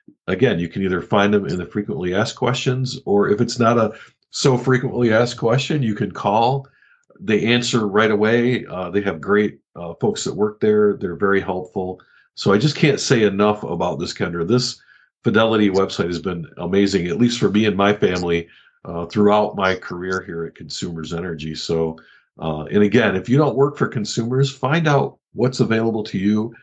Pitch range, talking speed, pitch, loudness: 100-130 Hz, 190 wpm, 110 Hz, -19 LUFS